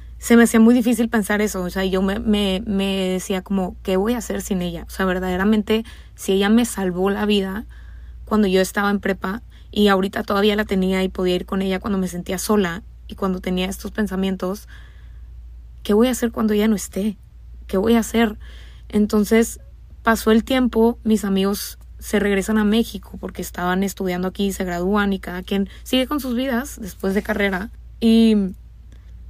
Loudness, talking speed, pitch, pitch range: -20 LUFS, 190 wpm, 200 Hz, 190-220 Hz